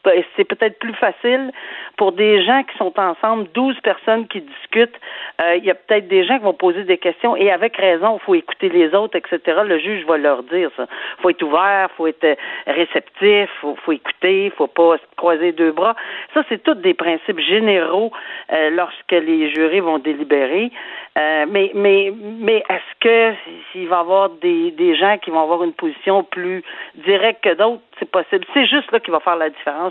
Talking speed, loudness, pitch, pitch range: 210 wpm, -17 LUFS, 195 Hz, 170-230 Hz